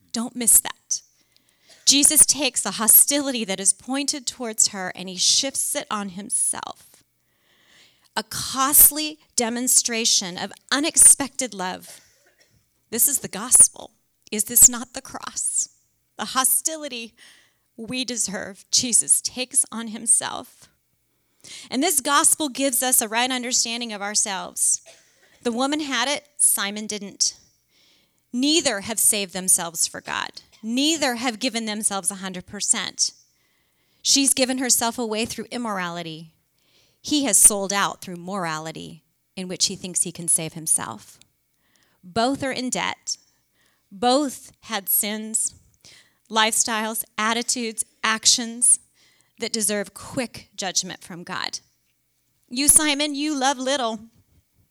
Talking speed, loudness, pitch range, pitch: 120 wpm, -19 LUFS, 200-260 Hz, 230 Hz